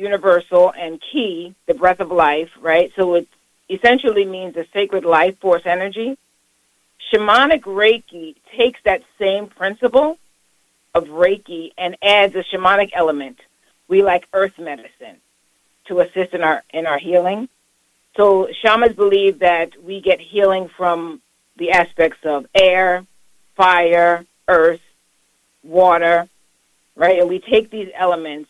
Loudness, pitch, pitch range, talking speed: -16 LUFS, 180 Hz, 170-195 Hz, 130 wpm